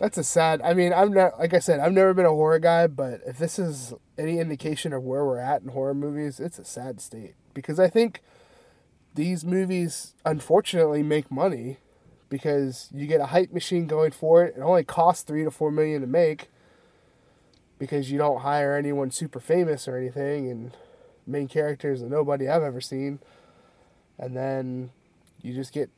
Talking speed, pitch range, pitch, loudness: 185 wpm, 135-170 Hz, 150 Hz, -24 LUFS